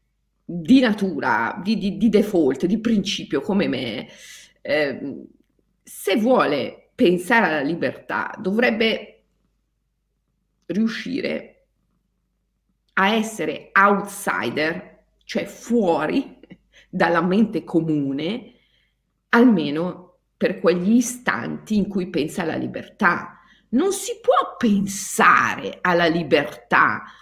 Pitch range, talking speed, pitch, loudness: 175-230 Hz, 90 wpm, 200 Hz, -21 LUFS